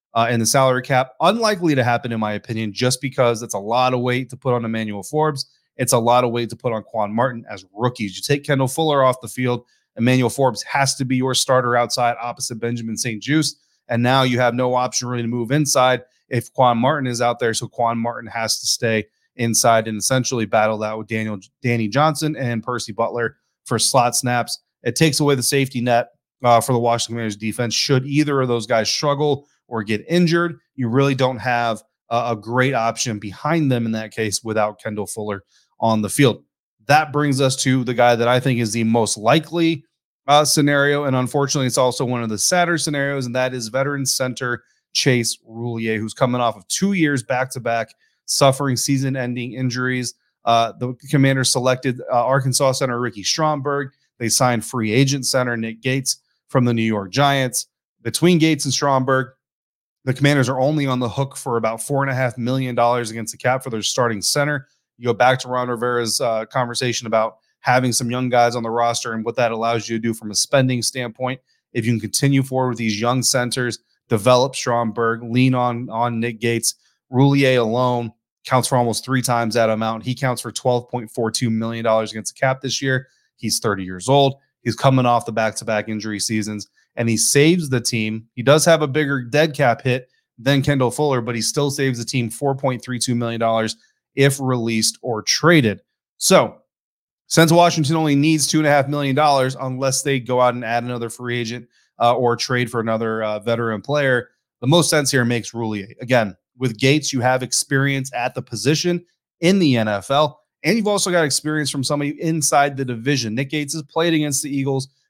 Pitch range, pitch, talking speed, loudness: 115-135 Hz, 125 Hz, 200 wpm, -19 LUFS